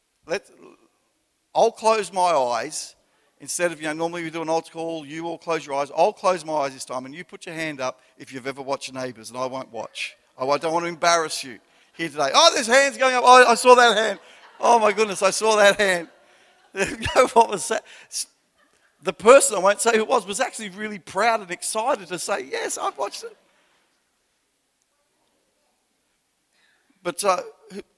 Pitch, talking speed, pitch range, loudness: 185 Hz, 195 wpm, 160-225 Hz, -21 LUFS